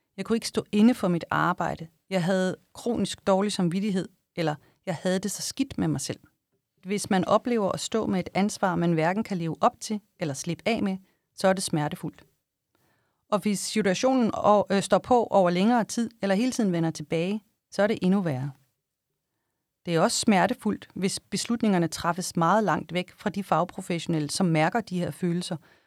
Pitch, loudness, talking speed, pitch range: 190 Hz, -26 LUFS, 185 wpm, 170-210 Hz